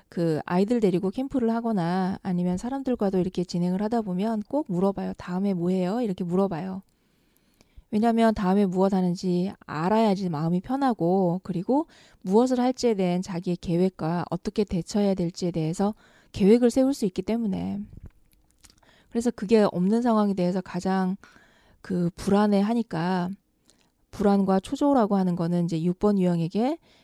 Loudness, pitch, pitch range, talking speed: -25 LUFS, 190 Hz, 175-220 Hz, 340 characters per minute